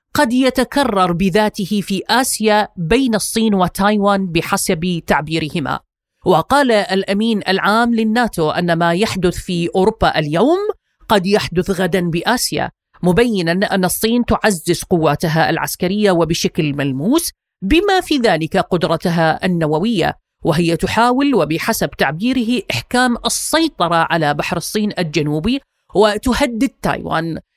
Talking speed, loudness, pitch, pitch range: 105 wpm, -16 LUFS, 195 Hz, 170-230 Hz